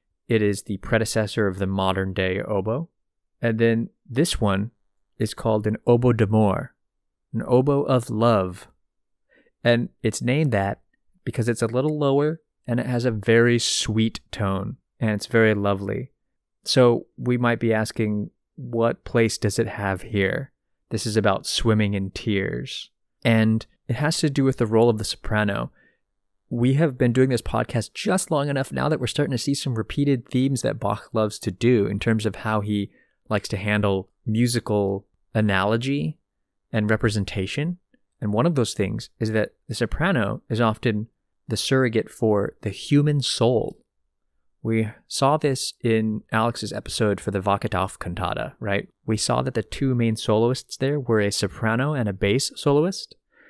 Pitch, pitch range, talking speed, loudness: 110 Hz, 105-125 Hz, 165 wpm, -23 LUFS